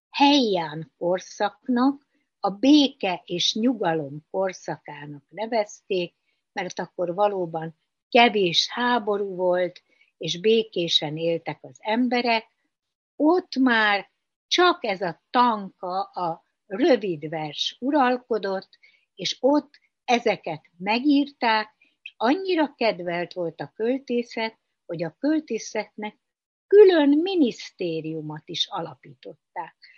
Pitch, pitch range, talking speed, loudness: 210 Hz, 175-255 Hz, 90 wpm, -23 LUFS